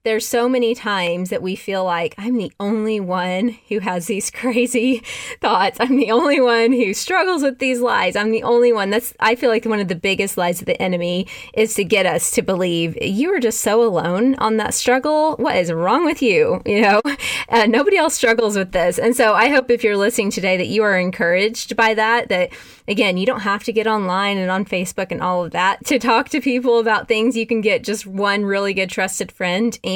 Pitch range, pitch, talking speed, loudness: 195-240 Hz, 220 Hz, 230 wpm, -17 LUFS